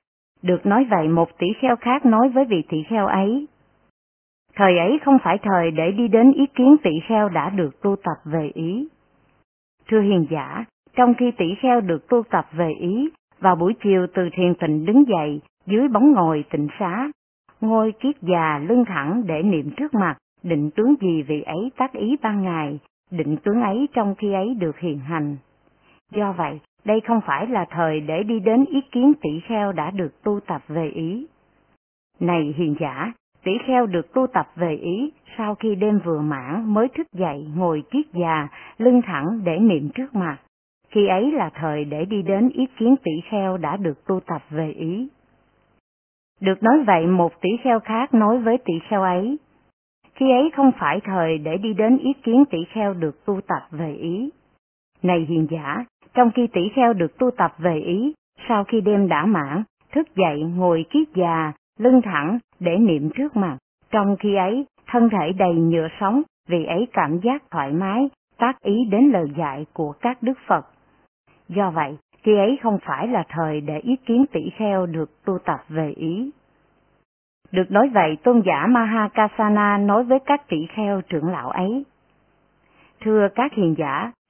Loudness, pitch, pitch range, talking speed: -20 LUFS, 195 Hz, 165-235 Hz, 185 wpm